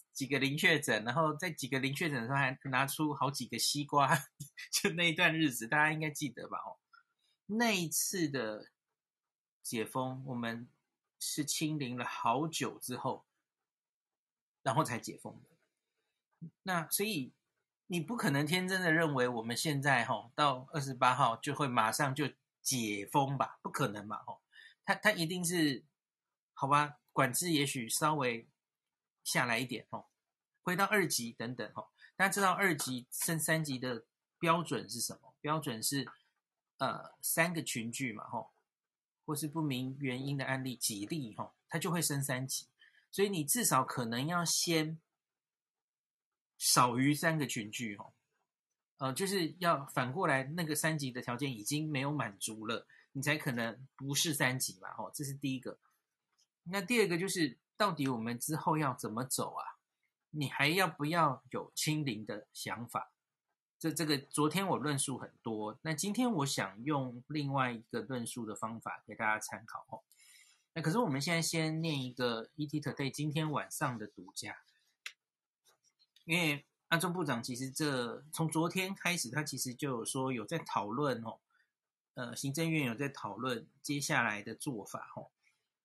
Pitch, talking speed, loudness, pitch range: 145 Hz, 235 characters per minute, -34 LUFS, 125-160 Hz